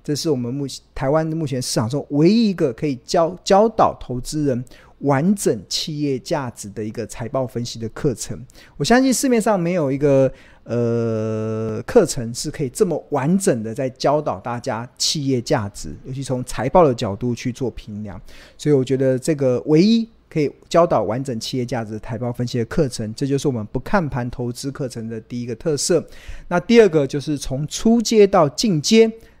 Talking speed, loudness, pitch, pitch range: 285 characters per minute, -20 LUFS, 135 Hz, 120-160 Hz